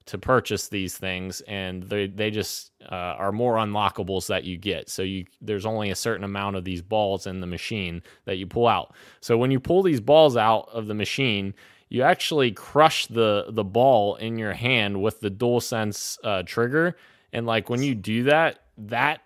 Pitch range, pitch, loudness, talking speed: 100-120 Hz, 105 Hz, -24 LUFS, 200 wpm